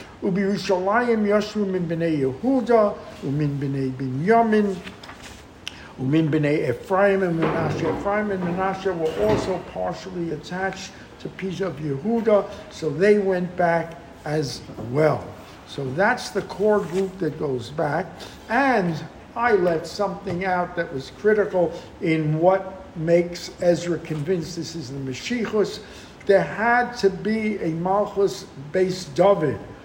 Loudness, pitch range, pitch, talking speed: -23 LUFS, 155-200 Hz, 180 Hz, 120 wpm